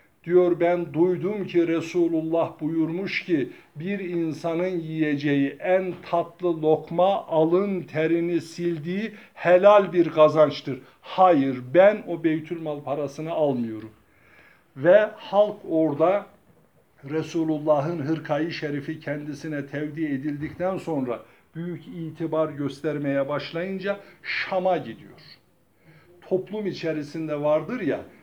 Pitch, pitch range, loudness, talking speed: 165 Hz, 150-175 Hz, -24 LUFS, 95 wpm